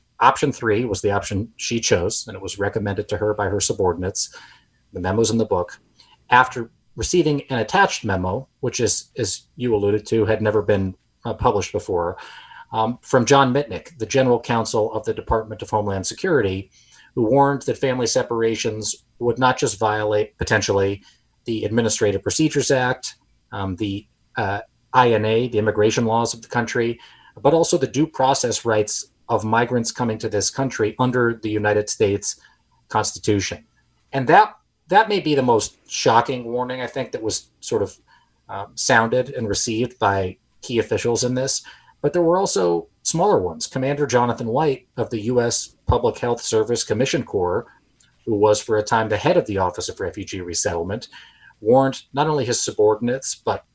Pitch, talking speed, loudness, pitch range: 115 Hz, 170 wpm, -21 LUFS, 105-125 Hz